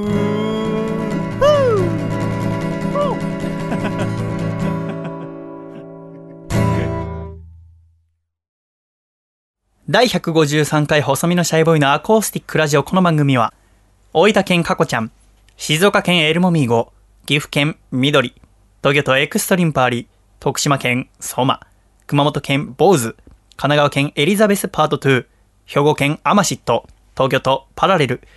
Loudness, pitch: -17 LUFS, 145 Hz